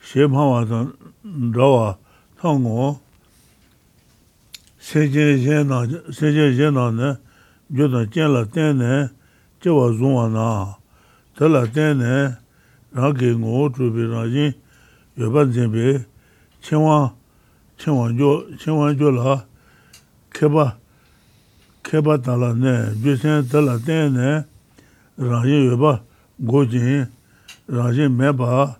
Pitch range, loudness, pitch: 120-145 Hz, -18 LUFS, 135 Hz